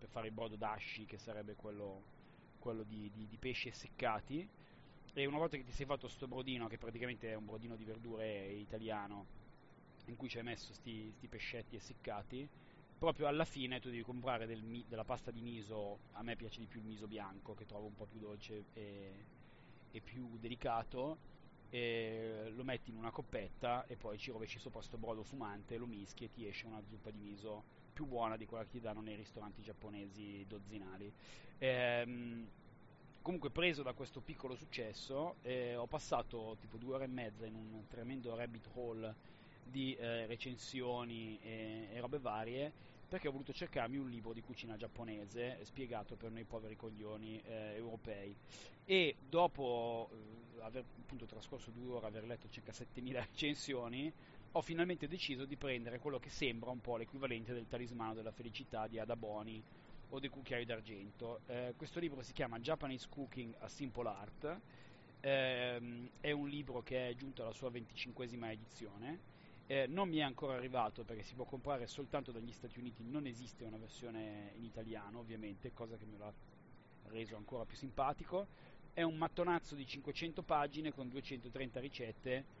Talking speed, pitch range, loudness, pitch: 170 wpm, 110-135 Hz, -45 LUFS, 120 Hz